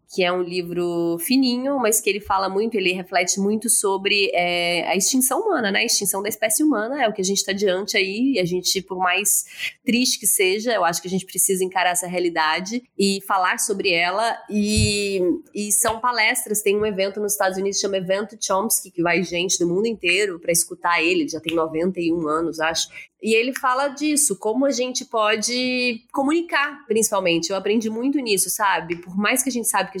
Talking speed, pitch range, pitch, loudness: 205 wpm, 180-235 Hz, 200 Hz, -20 LUFS